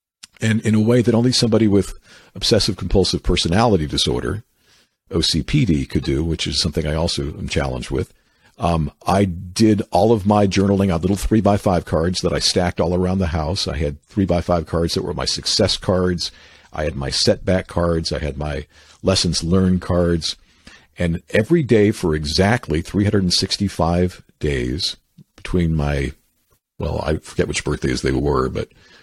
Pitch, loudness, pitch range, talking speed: 90 Hz, -19 LUFS, 80-100 Hz, 170 wpm